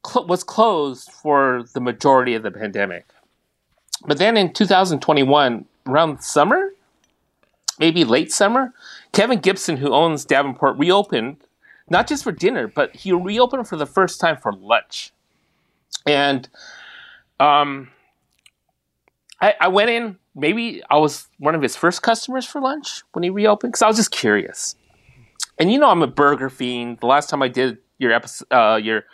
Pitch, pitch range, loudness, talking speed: 160 Hz, 135-215 Hz, -18 LUFS, 155 wpm